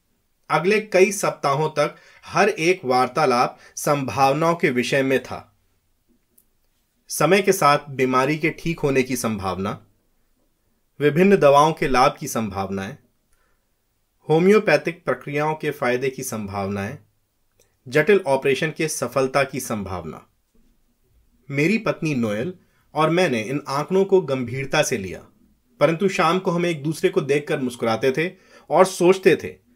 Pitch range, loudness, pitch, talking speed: 120-165 Hz, -20 LUFS, 140 Hz, 125 wpm